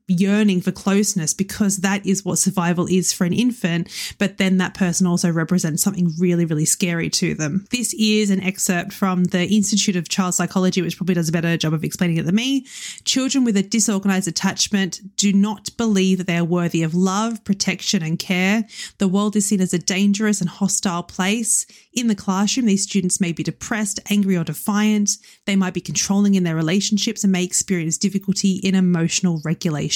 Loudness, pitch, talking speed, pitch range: -19 LUFS, 190 Hz, 195 wpm, 180-205 Hz